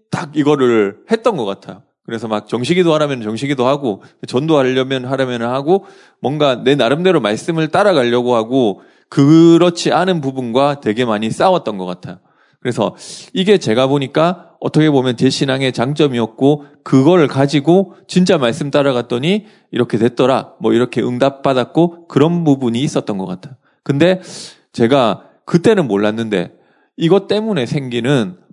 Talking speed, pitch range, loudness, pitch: 330 characters per minute, 120-170 Hz, -15 LUFS, 140 Hz